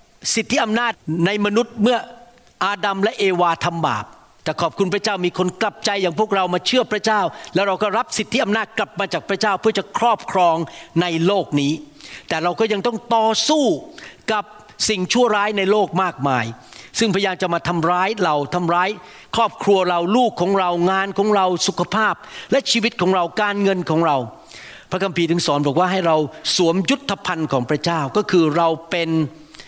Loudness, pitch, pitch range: -19 LUFS, 195 Hz, 170-215 Hz